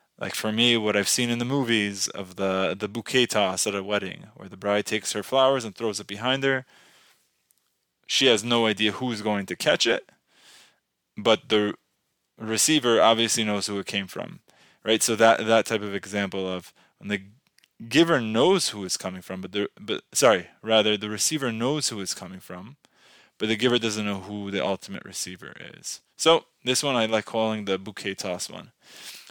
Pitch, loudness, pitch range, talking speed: 110 Hz, -24 LUFS, 100-115 Hz, 190 wpm